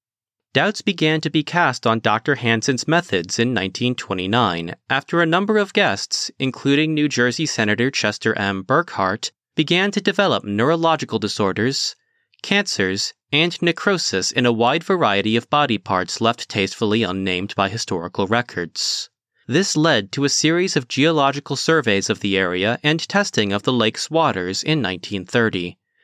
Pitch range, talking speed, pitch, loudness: 105-160 Hz, 145 wpm, 125 Hz, -19 LUFS